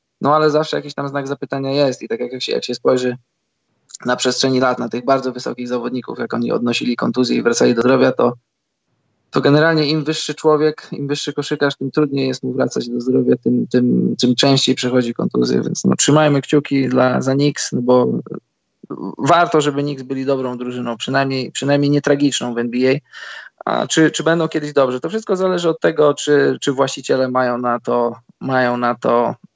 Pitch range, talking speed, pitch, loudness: 125-145 Hz, 190 wpm, 135 Hz, -17 LUFS